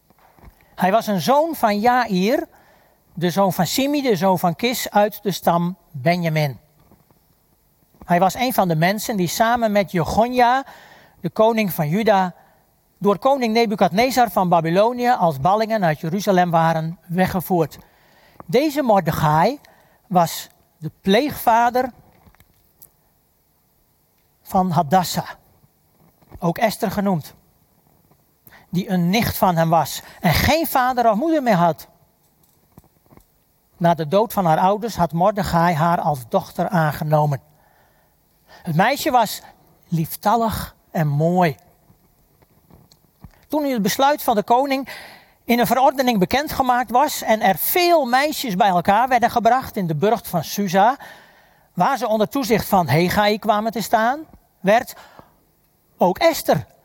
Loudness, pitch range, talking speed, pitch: -19 LUFS, 170-240 Hz, 130 wpm, 200 Hz